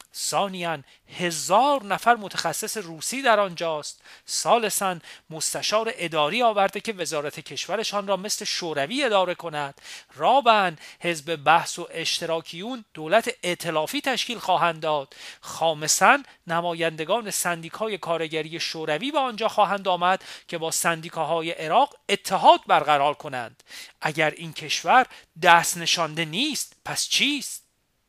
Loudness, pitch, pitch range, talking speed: -23 LUFS, 170 Hz, 160-210 Hz, 115 wpm